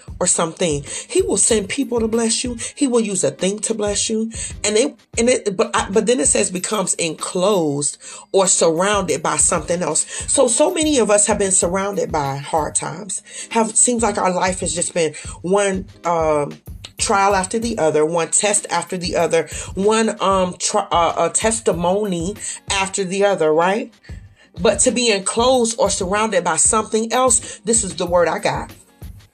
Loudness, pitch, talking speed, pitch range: -17 LUFS, 200 Hz, 185 wpm, 170-225 Hz